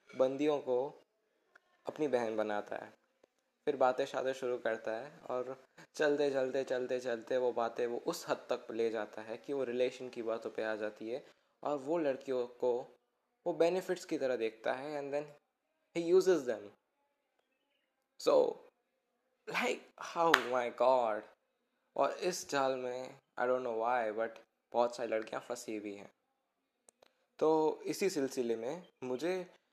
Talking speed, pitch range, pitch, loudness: 150 wpm, 120-165 Hz, 130 Hz, -36 LUFS